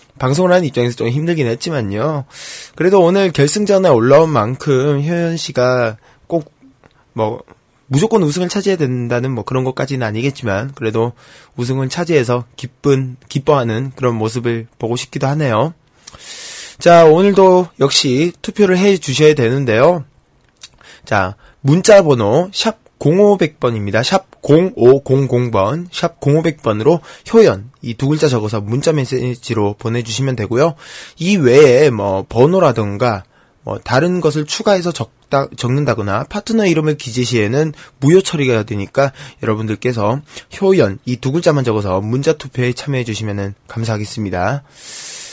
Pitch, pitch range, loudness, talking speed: 135 Hz, 120-165 Hz, -14 LUFS, 295 characters per minute